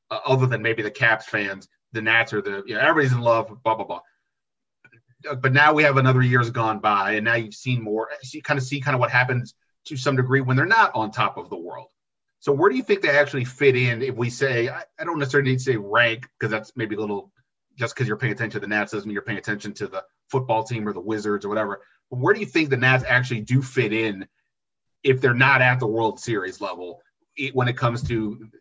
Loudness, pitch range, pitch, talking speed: -22 LUFS, 110-135 Hz, 125 Hz, 255 wpm